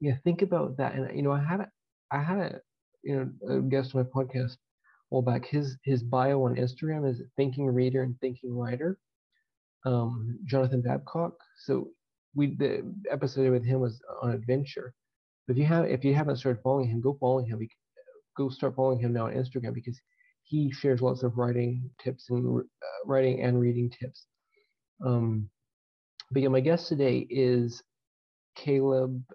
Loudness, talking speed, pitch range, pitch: -29 LUFS, 180 wpm, 125-140 Hz, 130 Hz